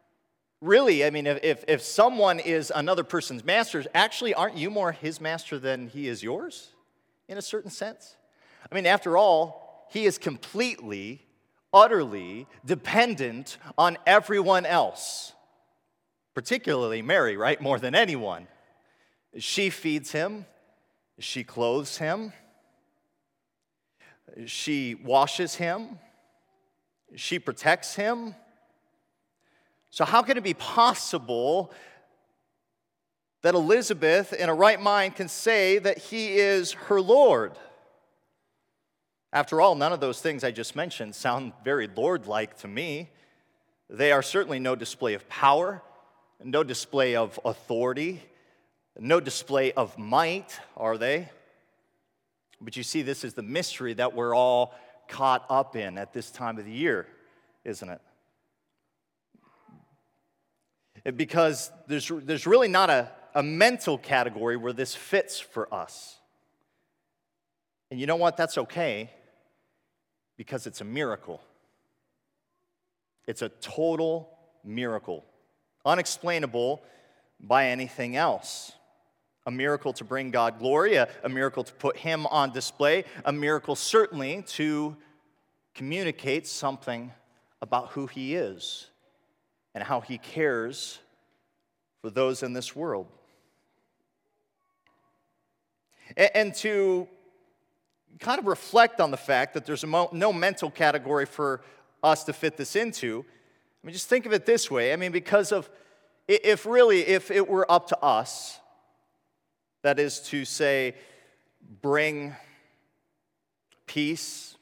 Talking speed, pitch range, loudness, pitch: 125 wpm, 130-205 Hz, -26 LUFS, 155 Hz